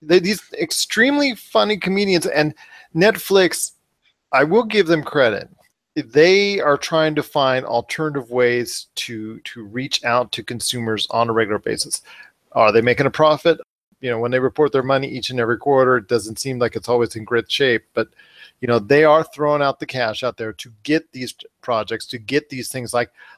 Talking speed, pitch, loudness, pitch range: 185 wpm, 135 Hz, -18 LUFS, 120-160 Hz